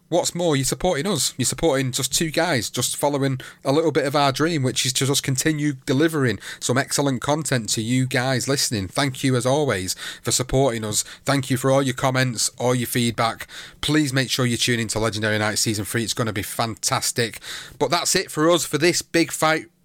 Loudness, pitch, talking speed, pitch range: -21 LUFS, 135 Hz, 220 wpm, 125-150 Hz